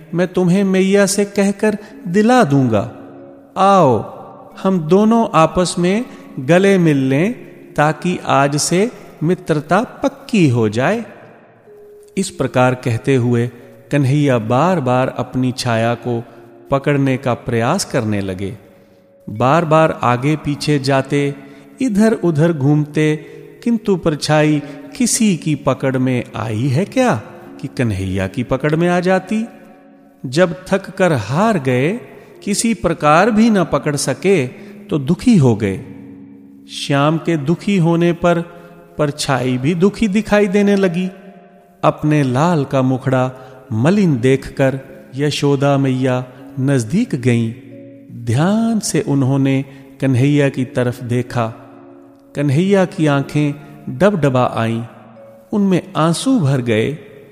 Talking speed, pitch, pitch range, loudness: 120 wpm, 145 Hz, 125-185 Hz, -16 LUFS